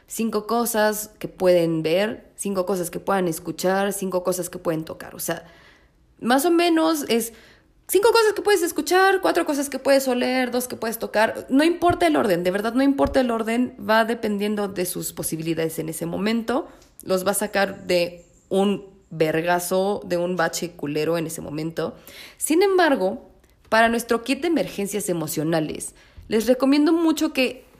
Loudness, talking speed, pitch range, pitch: -22 LUFS, 170 wpm, 175-265 Hz, 205 Hz